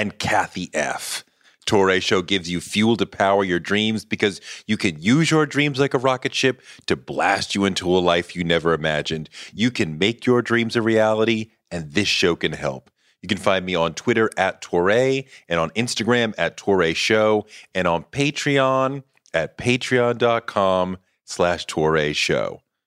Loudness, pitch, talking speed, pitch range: -21 LUFS, 110 Hz, 170 wpm, 90-125 Hz